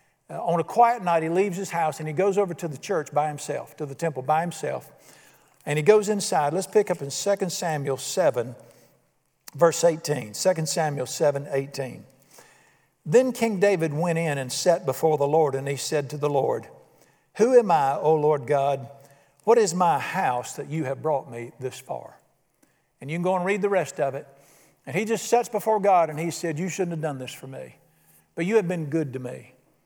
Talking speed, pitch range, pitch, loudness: 210 wpm, 140-185 Hz, 160 Hz, -24 LUFS